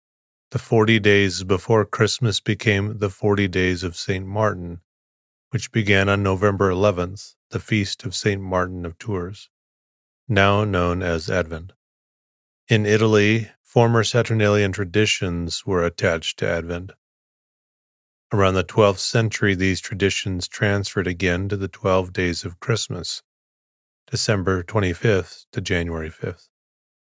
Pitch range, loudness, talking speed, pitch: 90-105 Hz, -21 LUFS, 125 wpm, 100 Hz